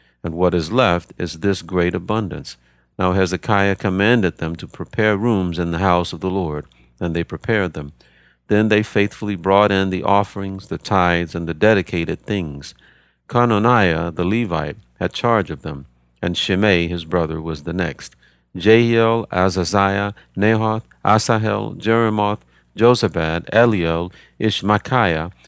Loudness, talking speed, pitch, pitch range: -18 LUFS, 140 wpm, 95 Hz, 85-105 Hz